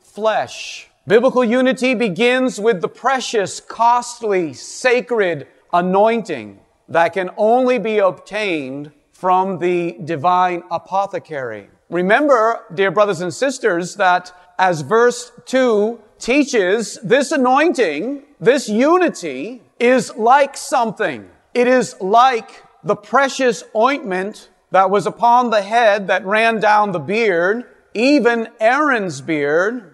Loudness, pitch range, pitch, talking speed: -16 LUFS, 185-255 Hz, 220 Hz, 110 wpm